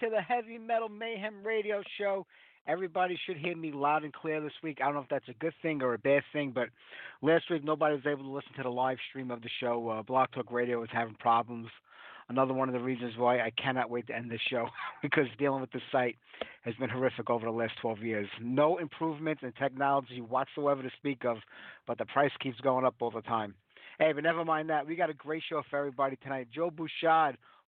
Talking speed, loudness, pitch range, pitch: 235 wpm, -32 LUFS, 120-155 Hz, 135 Hz